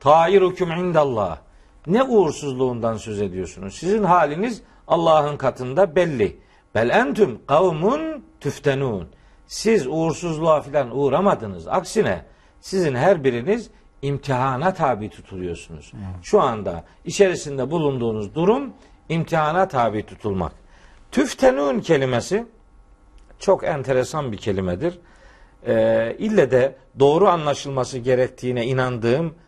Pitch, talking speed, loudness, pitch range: 140 Hz, 95 wpm, -21 LUFS, 115-180 Hz